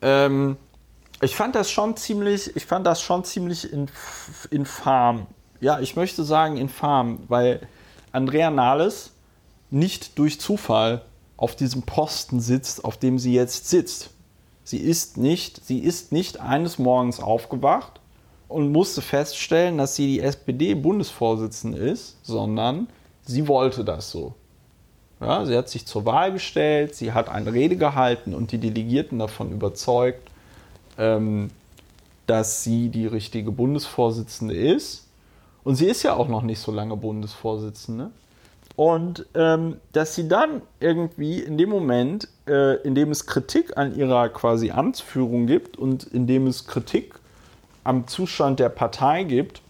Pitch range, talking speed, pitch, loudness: 115-155 Hz, 140 wpm, 130 Hz, -23 LUFS